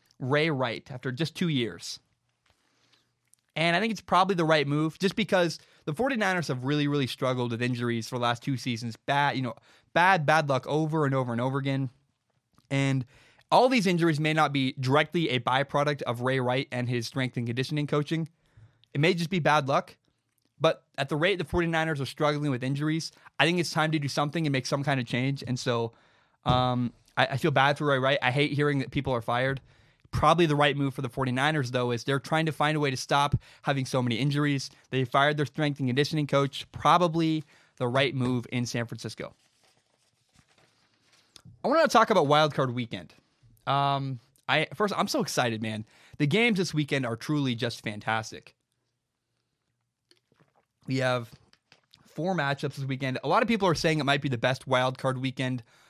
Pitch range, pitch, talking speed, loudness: 125-155 Hz, 140 Hz, 195 wpm, -27 LUFS